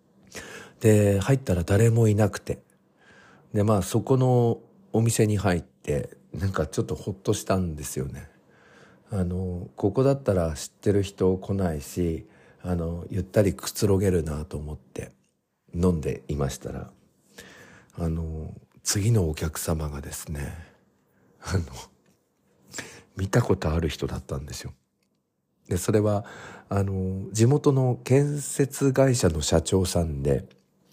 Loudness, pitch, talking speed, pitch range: -25 LUFS, 95 Hz, 245 characters per minute, 80-110 Hz